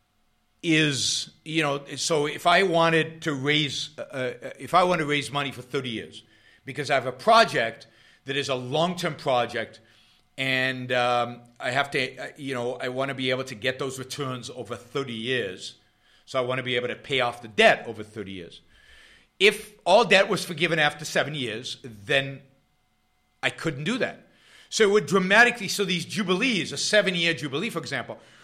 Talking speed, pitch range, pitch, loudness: 185 wpm, 125-165 Hz, 140 Hz, -24 LUFS